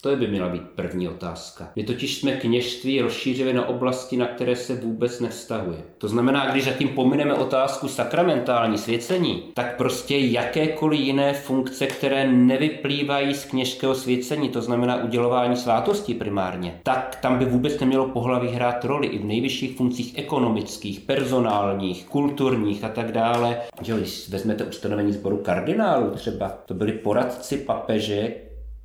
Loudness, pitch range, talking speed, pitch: -23 LUFS, 115-135 Hz, 150 wpm, 125 Hz